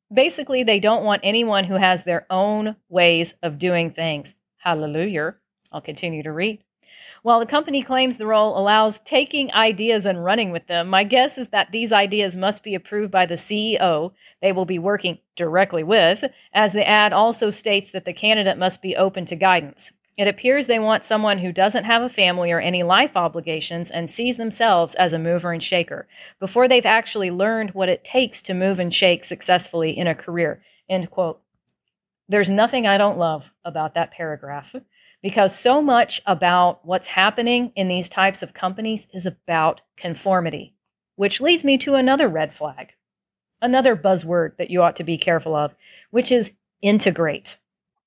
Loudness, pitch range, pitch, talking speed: -19 LUFS, 175-220 Hz, 195 Hz, 175 wpm